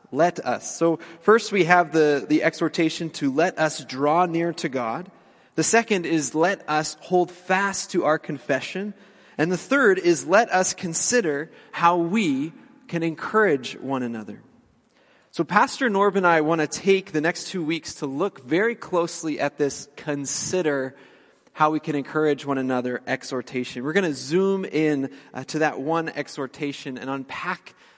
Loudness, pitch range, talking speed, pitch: -23 LUFS, 145-185 Hz, 165 wpm, 160 Hz